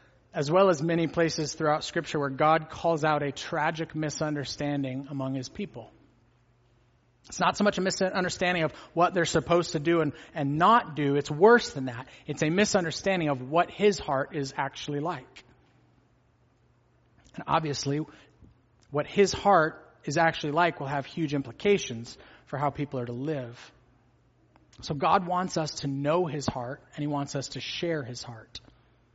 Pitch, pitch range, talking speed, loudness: 150 Hz, 130-170 Hz, 165 wpm, -27 LUFS